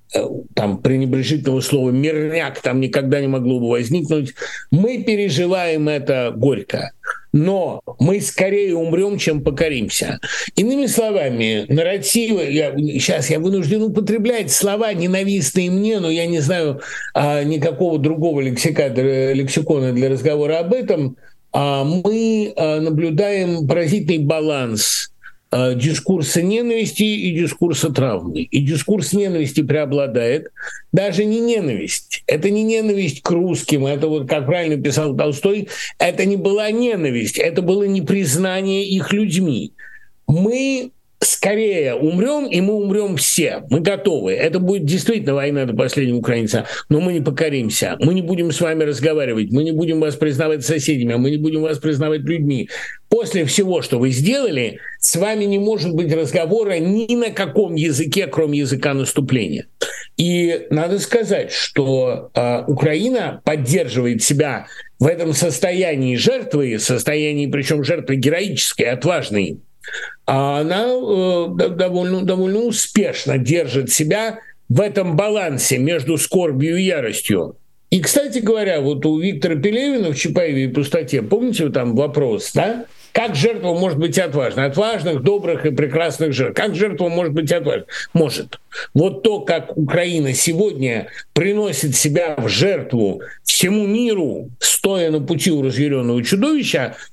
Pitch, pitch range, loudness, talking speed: 165 Hz, 145-195 Hz, -18 LUFS, 135 wpm